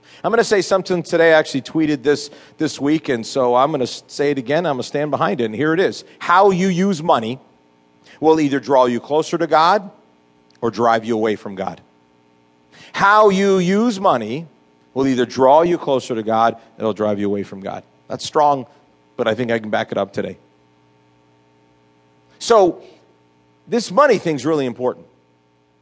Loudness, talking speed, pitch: -17 LUFS, 195 wpm, 115 Hz